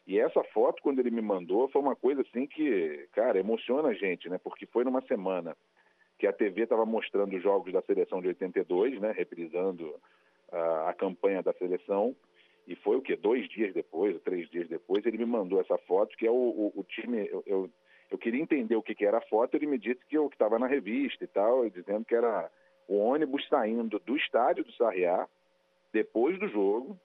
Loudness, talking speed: -30 LUFS, 215 wpm